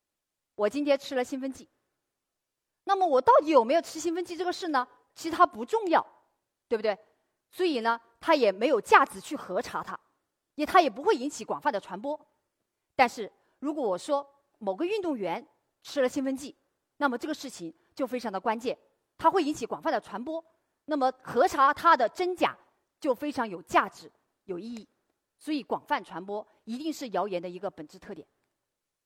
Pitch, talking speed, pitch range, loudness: 280 Hz, 270 characters per minute, 230-325 Hz, -28 LUFS